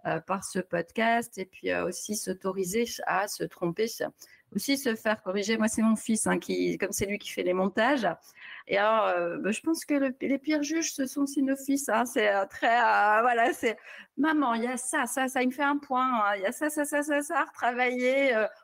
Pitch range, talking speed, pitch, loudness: 205-275 Hz, 240 wpm, 230 Hz, -28 LUFS